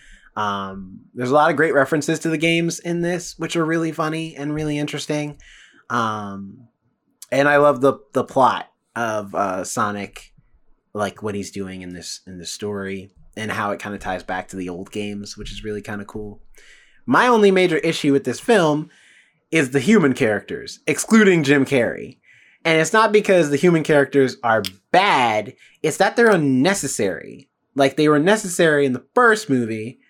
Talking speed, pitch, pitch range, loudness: 180 wpm, 140 Hz, 105-165 Hz, -19 LUFS